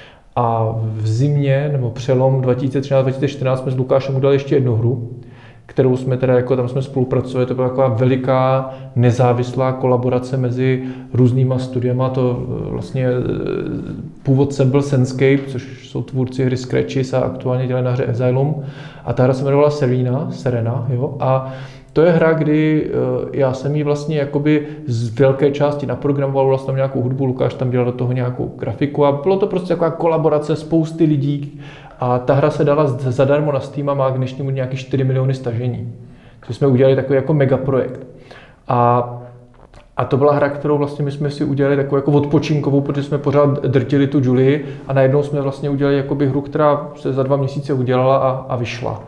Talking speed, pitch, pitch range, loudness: 175 wpm, 135 Hz, 125-145 Hz, -17 LUFS